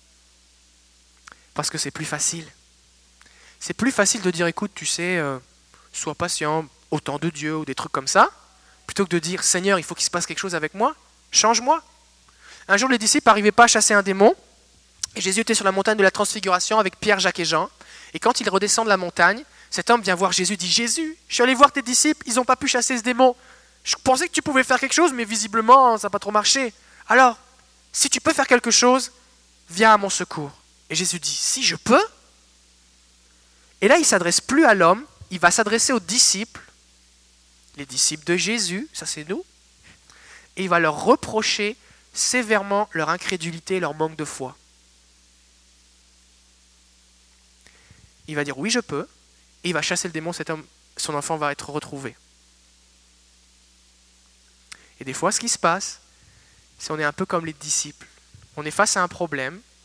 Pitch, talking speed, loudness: 175 Hz, 195 wpm, -20 LUFS